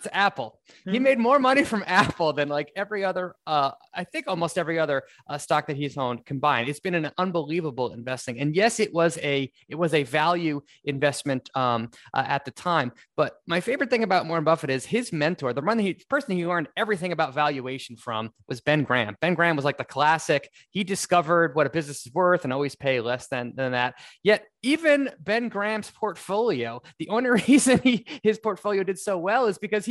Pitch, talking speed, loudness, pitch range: 165 Hz, 205 wpm, -25 LUFS, 140-205 Hz